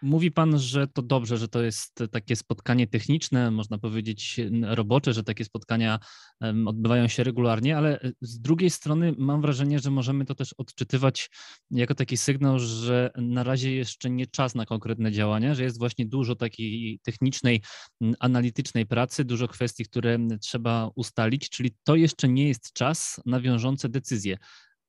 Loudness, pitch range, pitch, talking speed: -26 LUFS, 115-135 Hz, 125 Hz, 155 wpm